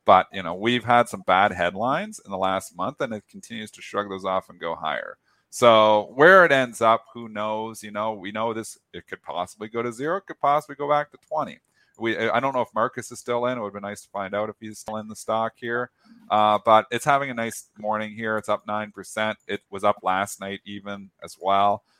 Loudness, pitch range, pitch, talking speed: -23 LUFS, 100-120 Hz, 110 Hz, 245 wpm